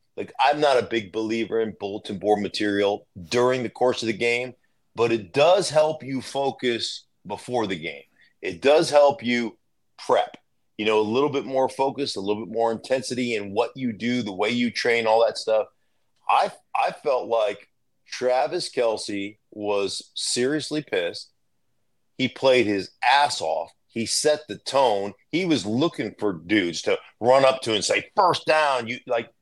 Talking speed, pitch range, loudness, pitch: 175 wpm, 105-135 Hz, -23 LUFS, 120 Hz